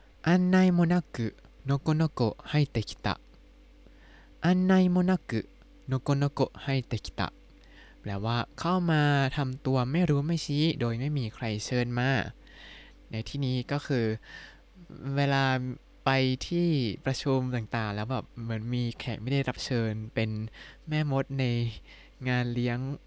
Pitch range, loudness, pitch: 115-145 Hz, -29 LUFS, 130 Hz